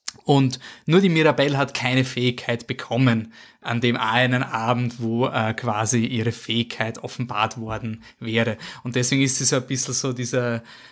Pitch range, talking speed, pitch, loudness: 115-130 Hz, 160 wpm, 125 Hz, -22 LUFS